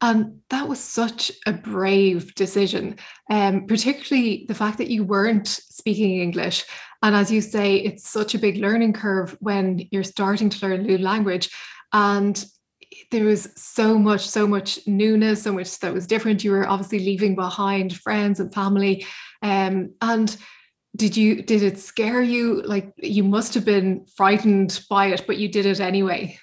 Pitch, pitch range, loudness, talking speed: 205 Hz, 195-215 Hz, -21 LUFS, 175 wpm